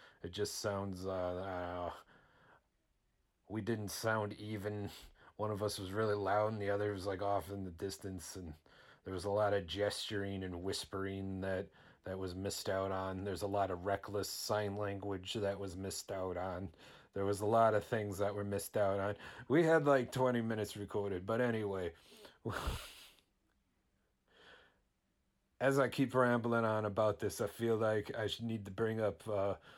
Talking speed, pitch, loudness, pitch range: 175 wpm, 100 Hz, -38 LUFS, 95-110 Hz